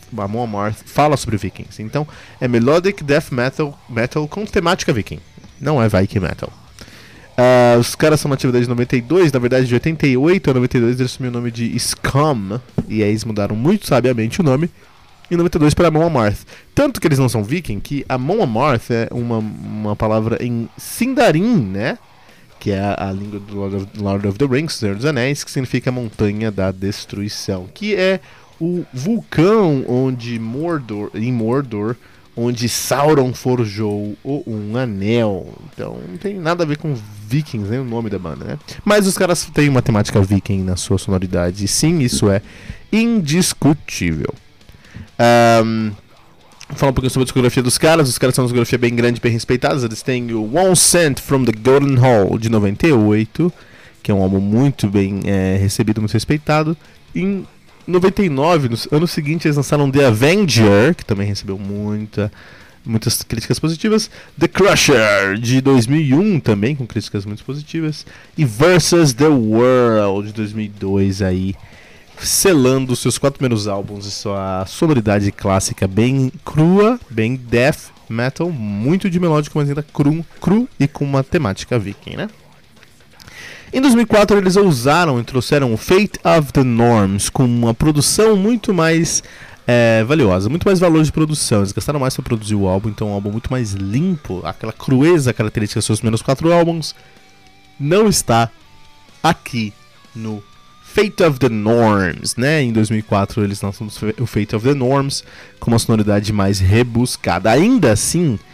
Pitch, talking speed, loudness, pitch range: 120 Hz, 165 wpm, -16 LUFS, 105-150 Hz